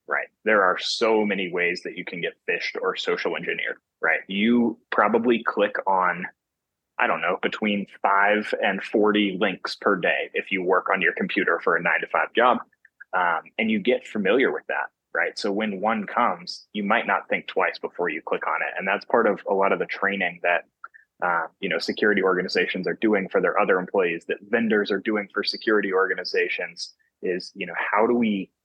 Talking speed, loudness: 205 wpm, -23 LUFS